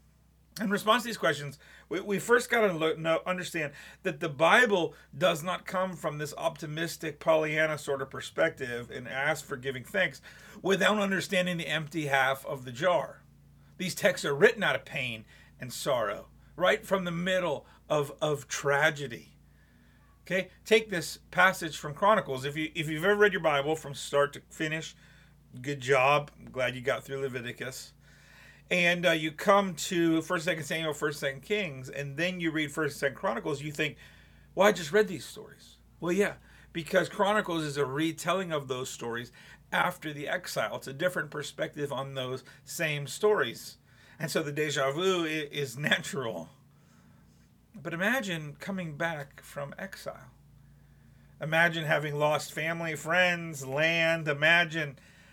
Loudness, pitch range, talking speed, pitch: -29 LUFS, 140-180 Hz, 160 wpm, 155 Hz